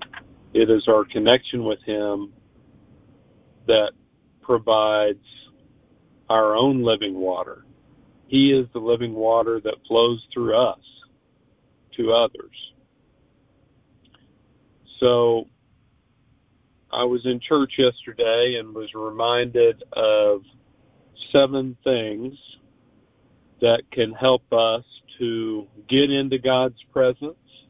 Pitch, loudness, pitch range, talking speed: 120 Hz, -21 LUFS, 110-130 Hz, 95 wpm